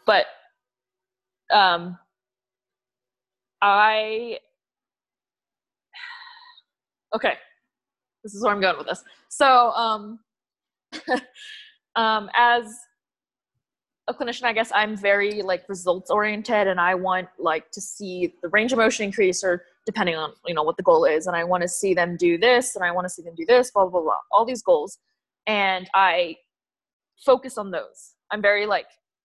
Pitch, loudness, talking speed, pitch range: 205 Hz, -22 LUFS, 155 wpm, 180-240 Hz